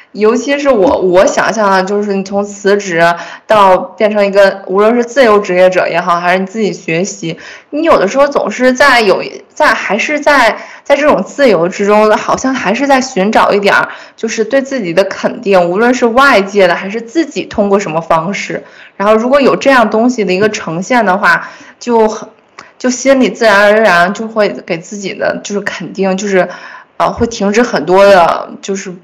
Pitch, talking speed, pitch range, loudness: 205 Hz, 280 characters per minute, 190-240 Hz, -10 LUFS